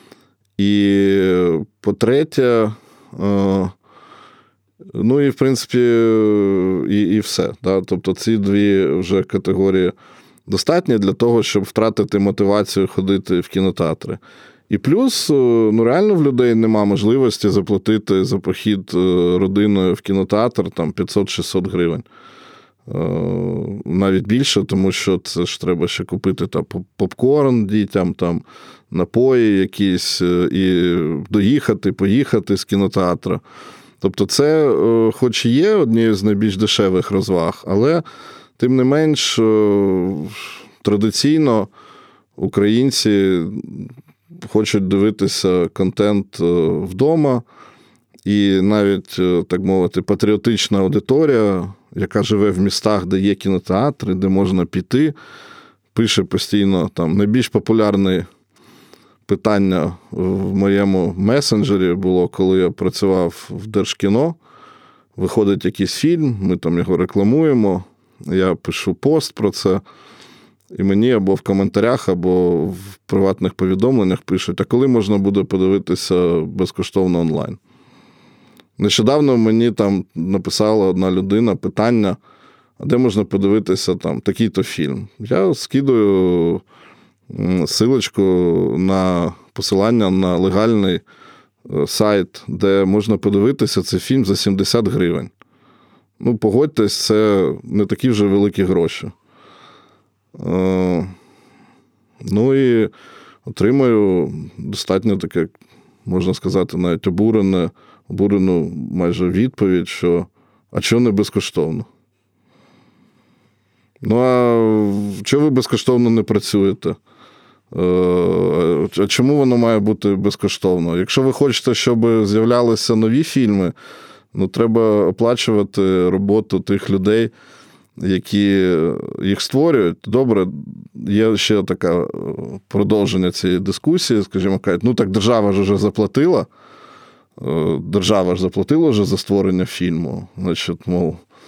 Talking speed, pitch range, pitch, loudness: 105 wpm, 95-110 Hz, 100 Hz, -17 LUFS